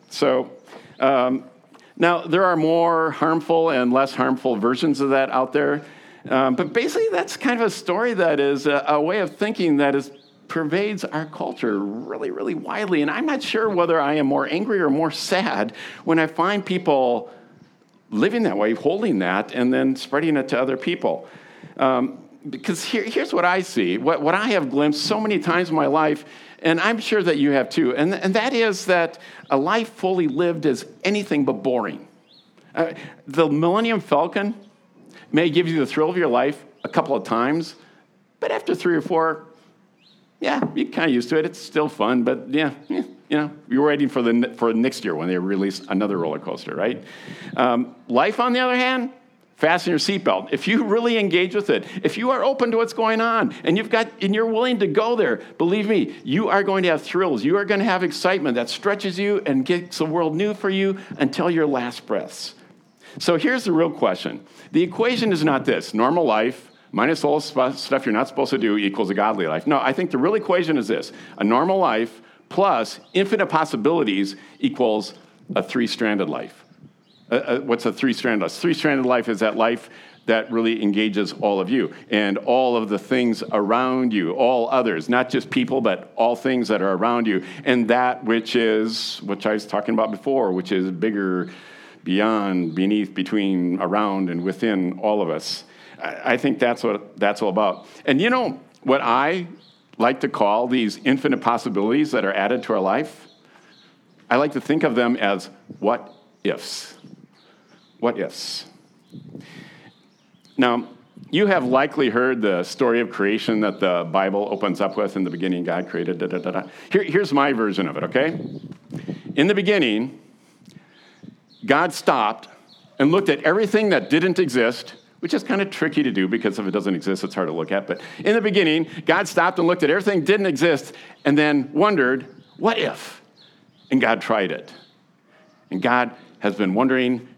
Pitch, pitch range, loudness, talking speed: 150 Hz, 115-185 Hz, -21 LUFS, 190 wpm